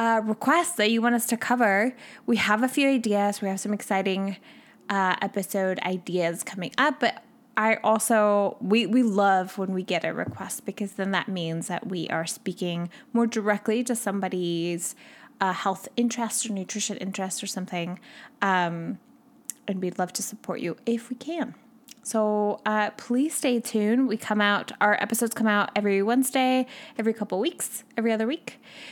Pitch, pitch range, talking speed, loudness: 215 Hz, 195-240 Hz, 170 wpm, -26 LUFS